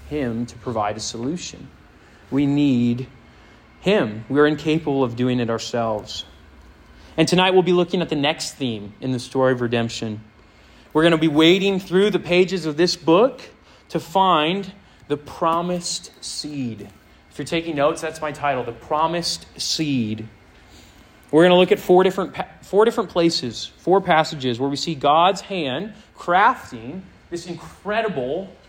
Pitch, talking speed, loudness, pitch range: 150 Hz, 160 wpm, -20 LUFS, 115-175 Hz